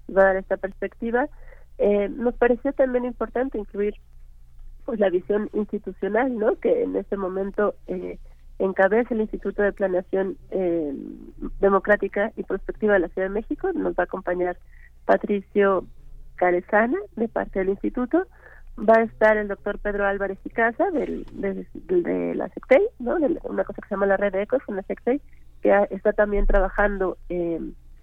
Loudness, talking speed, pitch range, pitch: -24 LUFS, 170 wpm, 190-230 Hz, 200 Hz